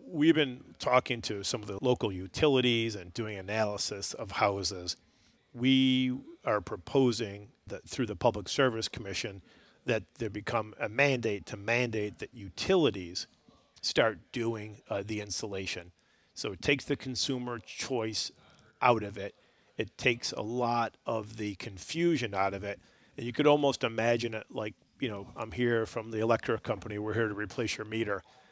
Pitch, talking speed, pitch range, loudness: 115 Hz, 160 wpm, 105-125 Hz, -31 LUFS